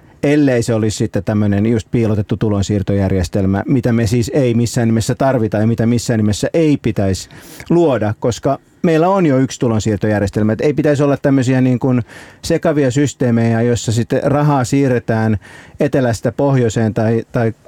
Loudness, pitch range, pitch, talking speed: -15 LUFS, 110-140 Hz, 120 Hz, 155 wpm